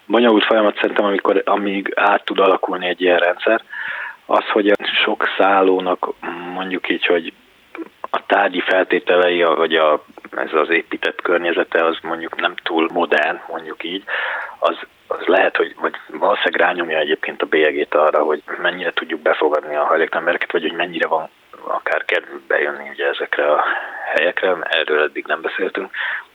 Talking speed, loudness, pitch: 150 wpm, -18 LUFS, 90 Hz